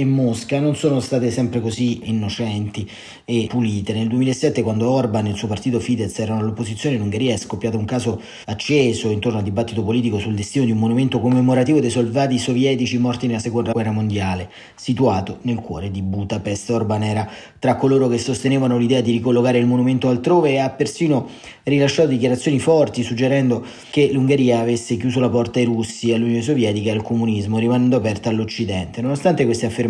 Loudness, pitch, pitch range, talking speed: -19 LUFS, 120 Hz, 110-130 Hz, 180 wpm